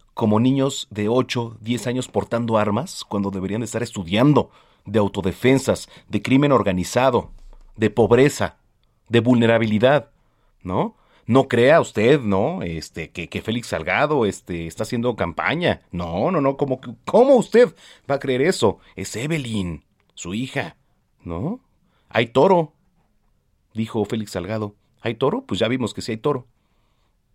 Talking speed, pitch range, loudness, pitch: 145 wpm, 100-130 Hz, -21 LUFS, 115 Hz